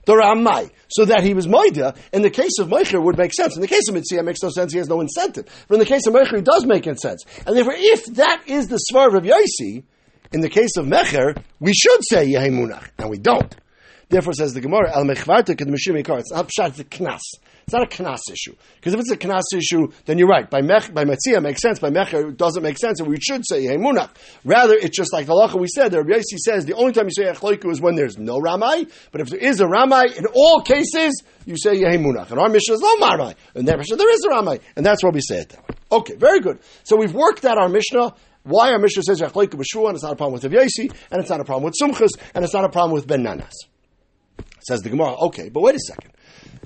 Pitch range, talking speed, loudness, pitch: 160-250 Hz, 255 wpm, -17 LUFS, 195 Hz